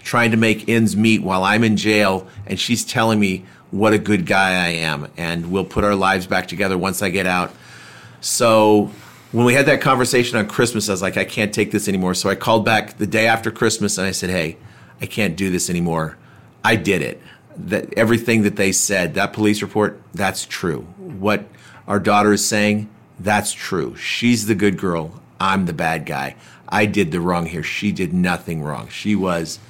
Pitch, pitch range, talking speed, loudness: 105 Hz, 95-110 Hz, 205 wpm, -18 LUFS